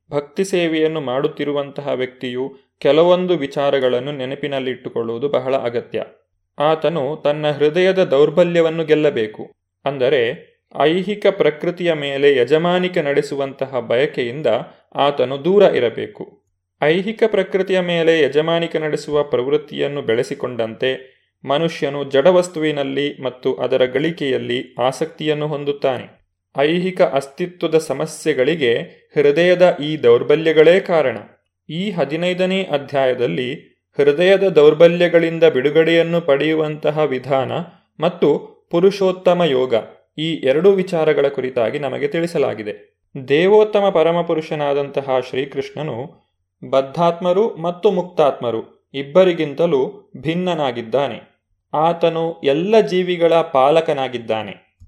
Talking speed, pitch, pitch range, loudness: 80 wpm, 155 Hz, 135-175 Hz, -17 LUFS